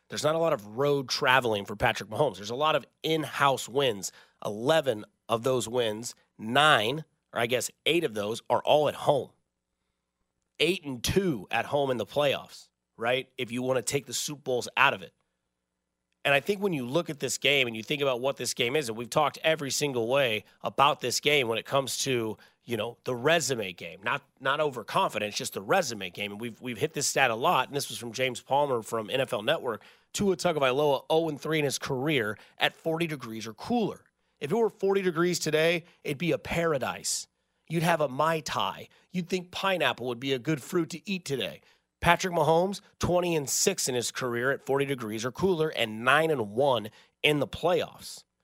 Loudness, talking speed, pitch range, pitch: -28 LUFS, 210 wpm, 120-160 Hz, 140 Hz